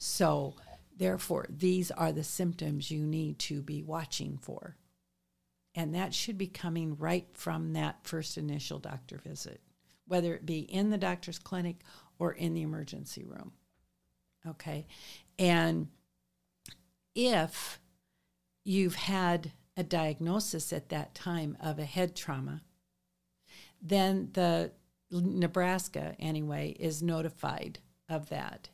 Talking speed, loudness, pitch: 120 wpm, -34 LUFS, 160 Hz